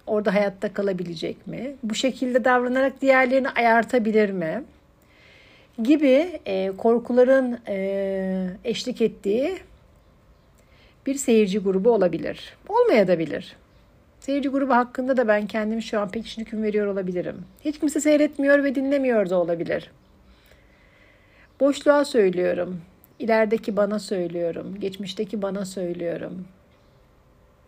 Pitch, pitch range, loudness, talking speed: 220 Hz, 190-260 Hz, -23 LUFS, 110 wpm